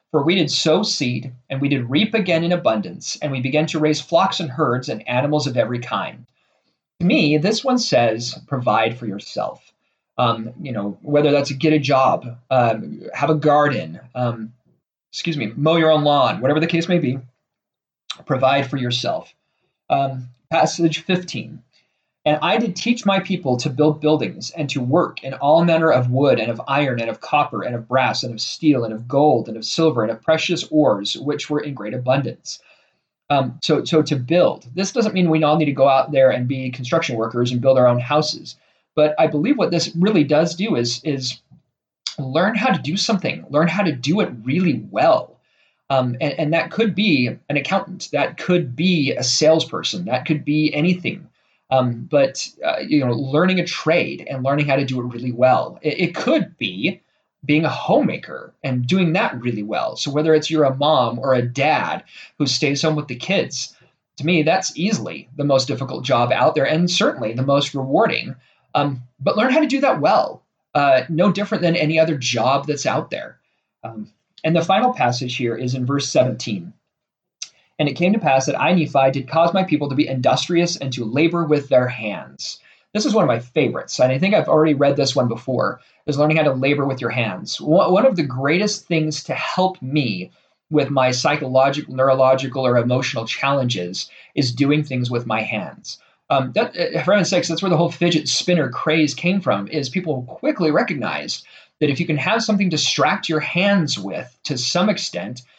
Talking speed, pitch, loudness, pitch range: 200 wpm, 150 Hz, -19 LUFS, 130-165 Hz